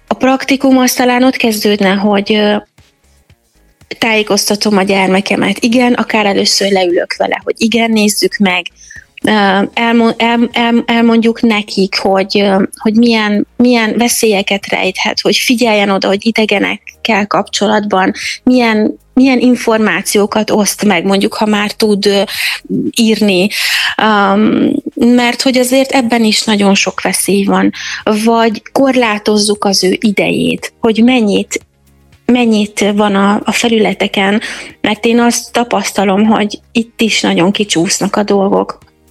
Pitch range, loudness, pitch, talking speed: 195-235 Hz, -11 LUFS, 215 Hz, 115 wpm